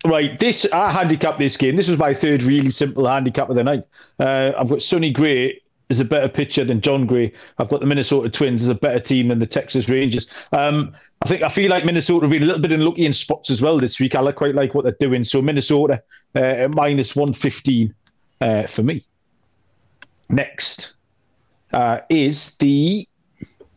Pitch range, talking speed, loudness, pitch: 130-155 Hz, 200 wpm, -18 LUFS, 140 Hz